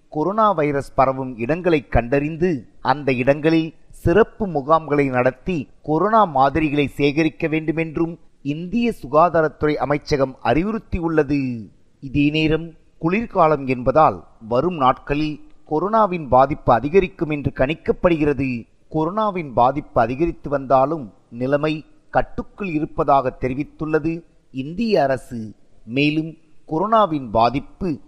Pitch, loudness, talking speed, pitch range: 155 Hz, -20 LUFS, 90 wpm, 135-165 Hz